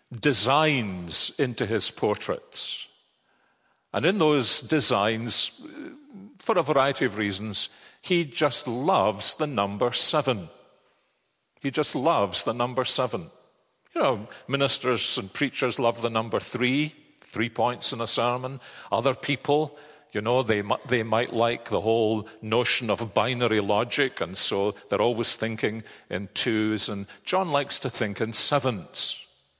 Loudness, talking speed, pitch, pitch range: -24 LUFS, 135 wpm, 125 Hz, 110-145 Hz